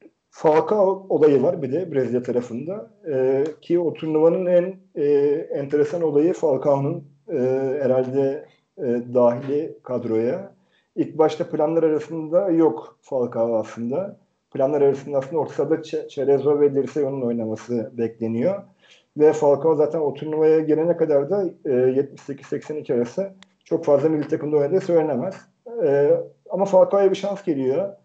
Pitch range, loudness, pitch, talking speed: 135-175 Hz, -21 LUFS, 150 Hz, 130 wpm